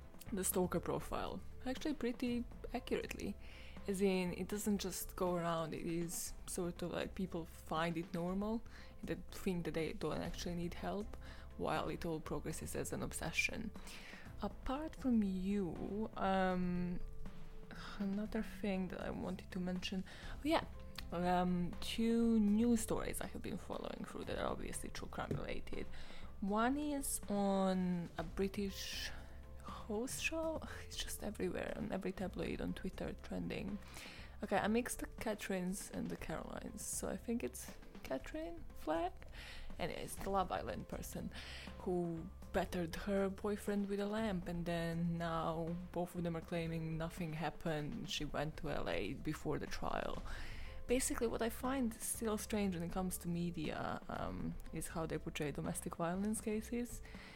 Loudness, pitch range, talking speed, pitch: -41 LUFS, 165-215 Hz, 150 wpm, 185 Hz